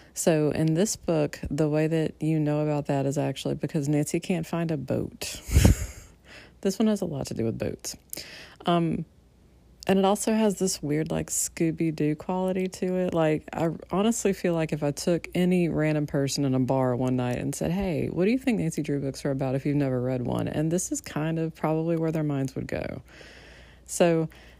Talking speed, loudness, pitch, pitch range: 210 wpm, -27 LUFS, 155 Hz, 135-175 Hz